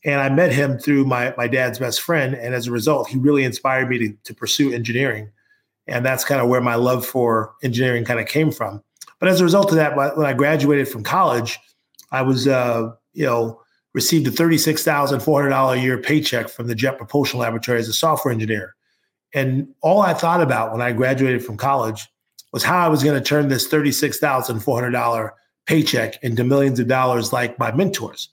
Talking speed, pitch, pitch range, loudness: 220 wpm, 130 Hz, 120-145 Hz, -19 LUFS